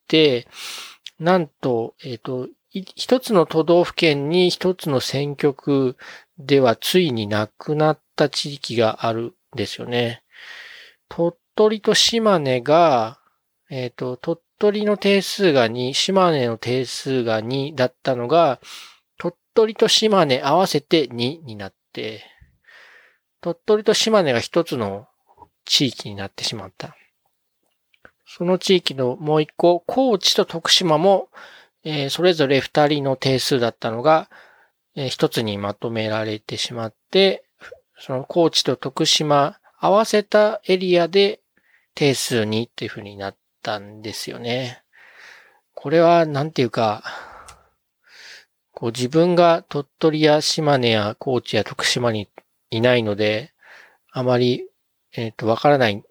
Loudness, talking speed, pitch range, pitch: -19 LUFS, 235 characters per minute, 120-175 Hz, 145 Hz